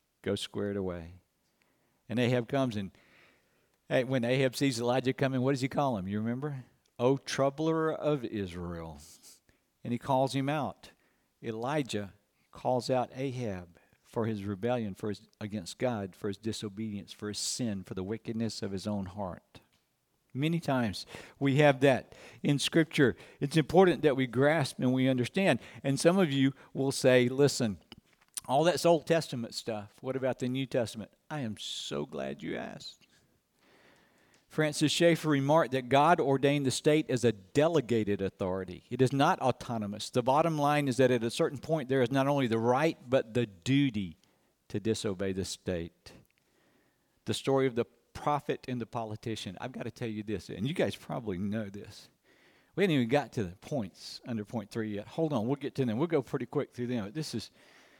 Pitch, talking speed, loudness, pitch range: 125 Hz, 180 wpm, -31 LUFS, 105-140 Hz